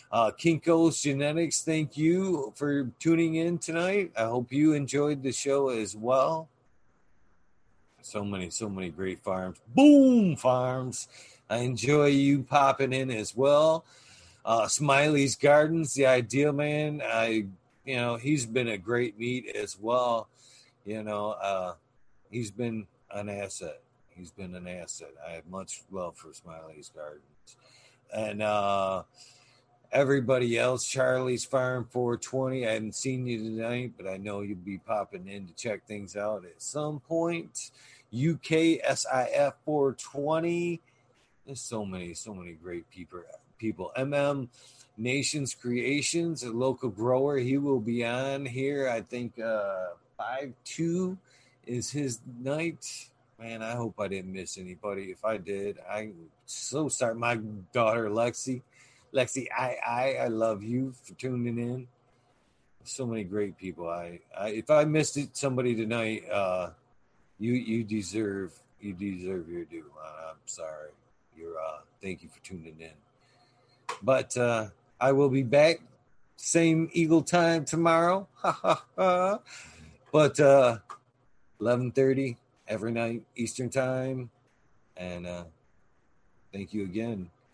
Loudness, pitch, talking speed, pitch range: -28 LUFS, 120 Hz, 135 wpm, 105-140 Hz